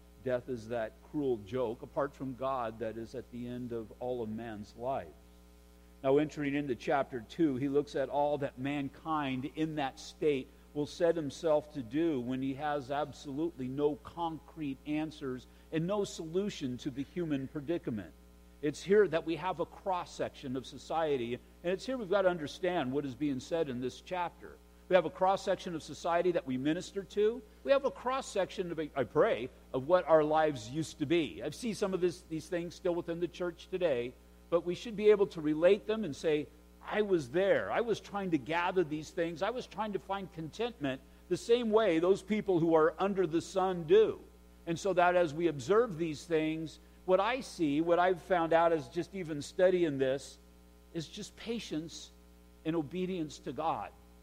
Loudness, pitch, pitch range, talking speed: -33 LUFS, 160 Hz, 135-185 Hz, 195 wpm